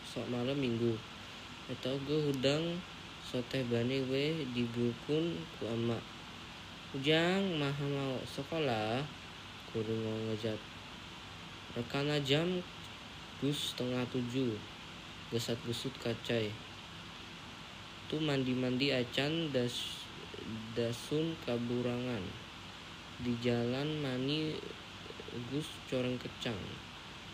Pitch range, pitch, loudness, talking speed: 110-140 Hz, 125 Hz, -36 LUFS, 90 wpm